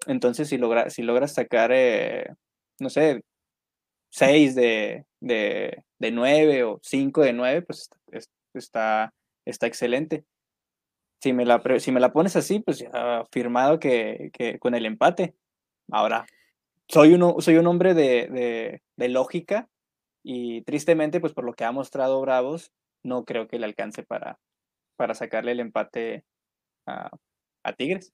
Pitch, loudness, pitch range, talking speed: 135 Hz, -23 LUFS, 120-165 Hz, 155 wpm